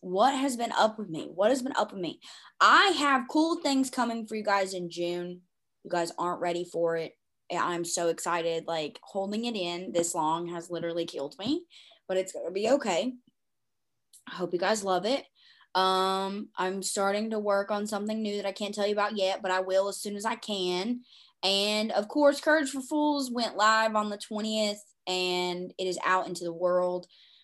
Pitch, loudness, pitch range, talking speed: 200 Hz, -29 LUFS, 180-230 Hz, 205 wpm